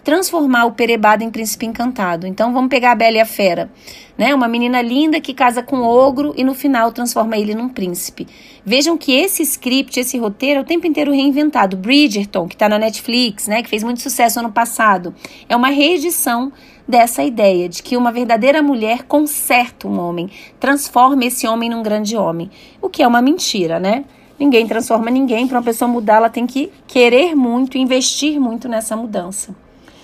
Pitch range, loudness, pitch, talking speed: 220-275 Hz, -15 LUFS, 240 Hz, 190 wpm